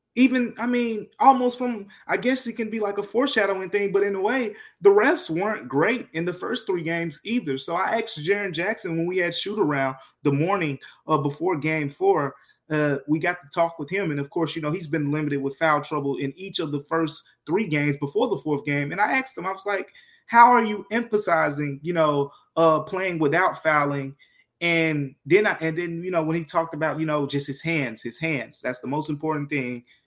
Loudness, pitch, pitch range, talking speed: -24 LUFS, 165 Hz, 150-205 Hz, 225 wpm